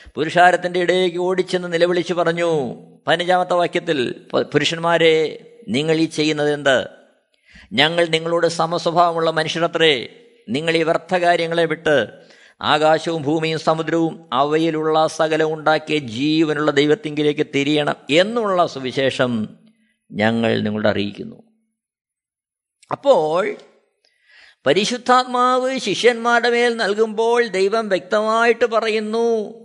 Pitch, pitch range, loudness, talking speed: 170 Hz, 155-220 Hz, -18 LUFS, 85 wpm